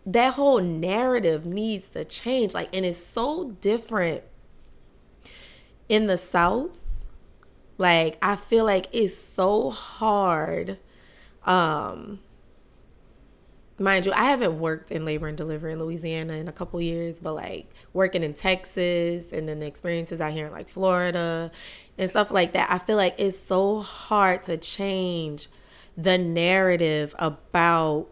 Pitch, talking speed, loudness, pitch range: 180 Hz, 140 wpm, -24 LUFS, 165-200 Hz